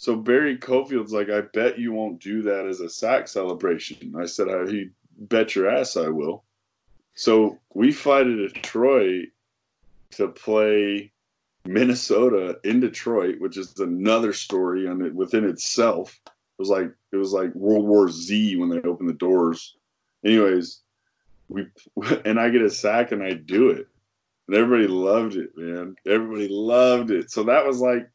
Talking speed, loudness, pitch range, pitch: 165 wpm, -22 LUFS, 95-120 Hz, 105 Hz